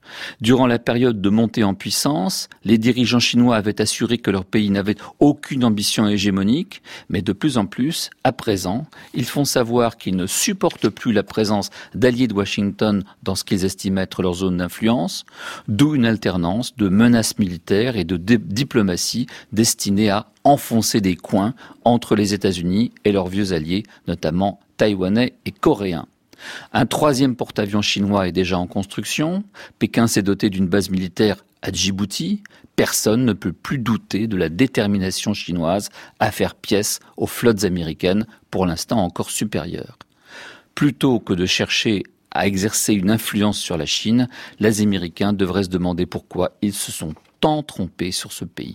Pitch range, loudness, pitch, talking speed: 95-115 Hz, -20 LUFS, 105 Hz, 160 wpm